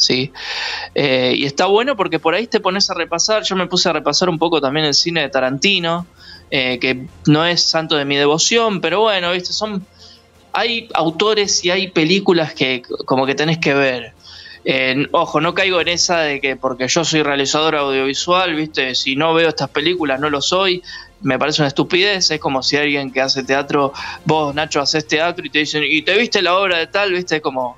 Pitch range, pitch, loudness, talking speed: 140-180 Hz, 155 Hz, -16 LUFS, 215 wpm